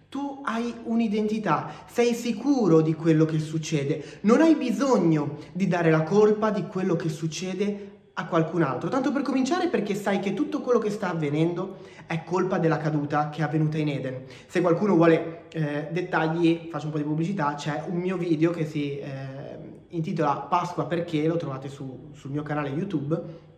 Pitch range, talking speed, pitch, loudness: 150-200 Hz, 180 wpm, 165 Hz, -25 LUFS